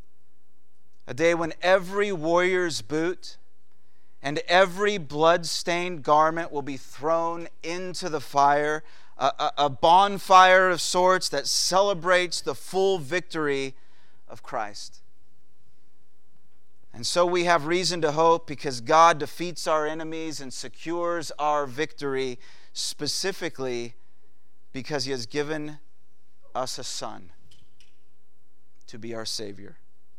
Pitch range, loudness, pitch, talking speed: 115-170 Hz, -24 LUFS, 150 Hz, 110 wpm